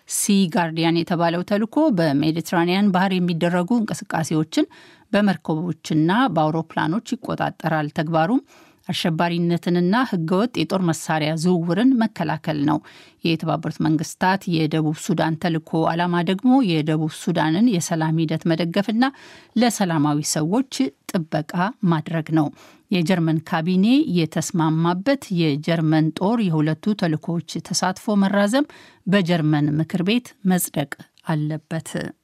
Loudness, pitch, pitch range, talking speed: -21 LUFS, 175 Hz, 160-200 Hz, 95 wpm